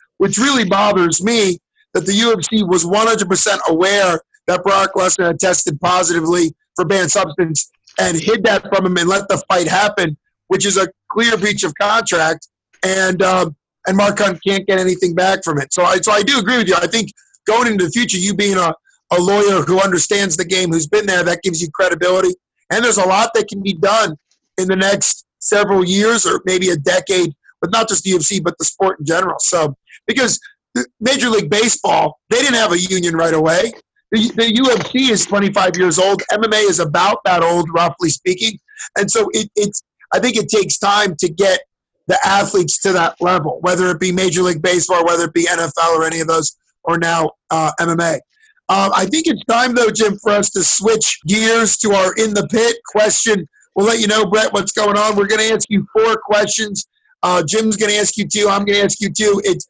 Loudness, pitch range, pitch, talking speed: -14 LUFS, 180-210 Hz, 195 Hz, 215 wpm